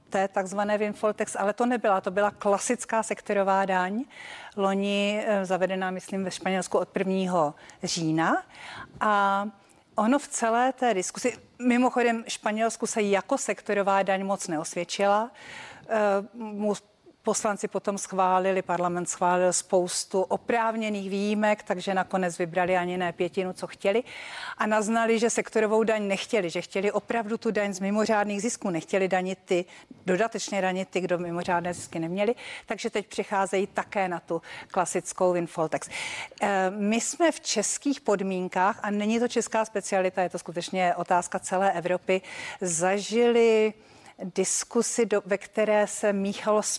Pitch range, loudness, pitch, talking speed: 185-220 Hz, -27 LUFS, 200 Hz, 130 wpm